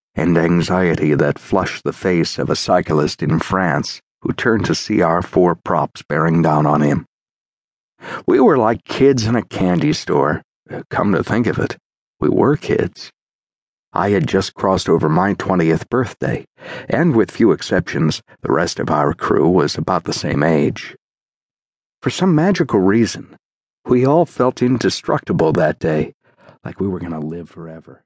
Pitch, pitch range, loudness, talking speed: 95 Hz, 80-125 Hz, -17 LUFS, 165 wpm